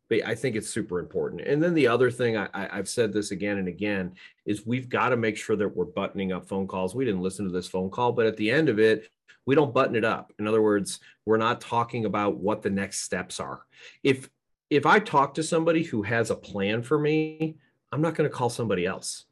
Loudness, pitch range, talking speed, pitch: -26 LUFS, 100-135 Hz, 245 wpm, 110 Hz